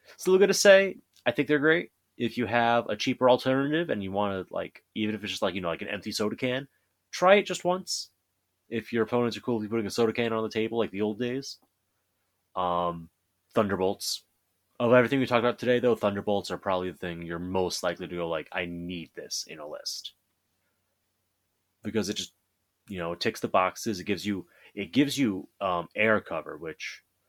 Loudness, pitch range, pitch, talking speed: -27 LUFS, 90-120 Hz, 105 Hz, 210 wpm